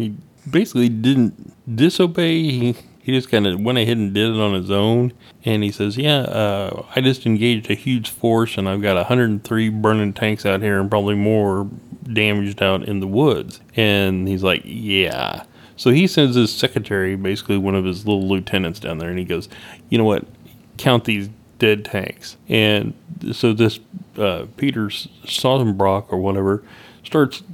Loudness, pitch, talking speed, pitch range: -19 LUFS, 110 Hz, 175 wpm, 100-125 Hz